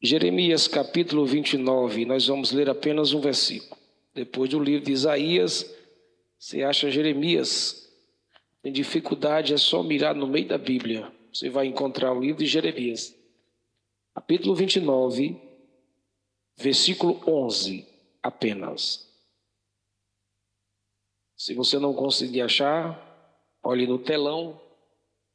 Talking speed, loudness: 110 wpm, -24 LUFS